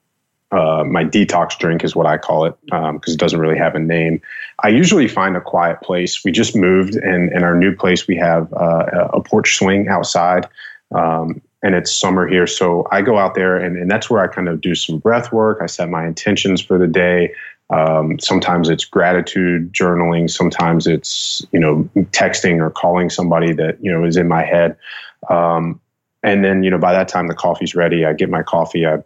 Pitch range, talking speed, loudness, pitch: 85-90 Hz, 210 wpm, -15 LUFS, 85 Hz